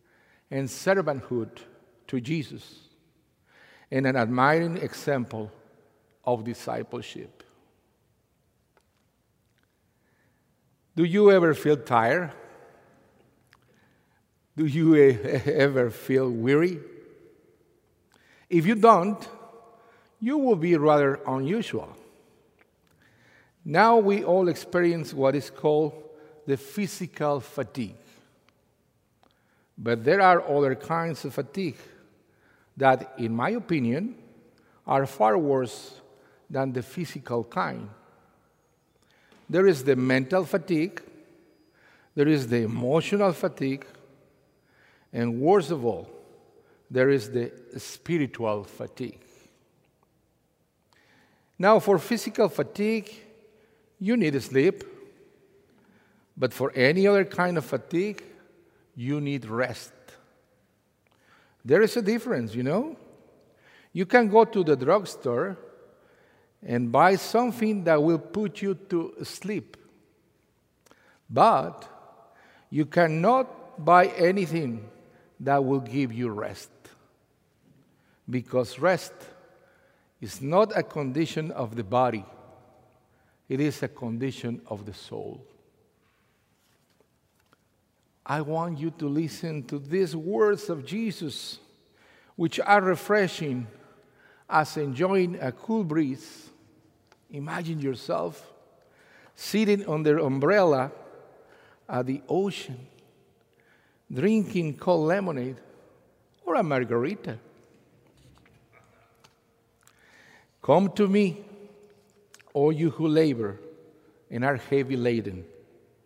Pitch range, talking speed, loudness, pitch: 130-195 Hz, 95 wpm, -25 LUFS, 155 Hz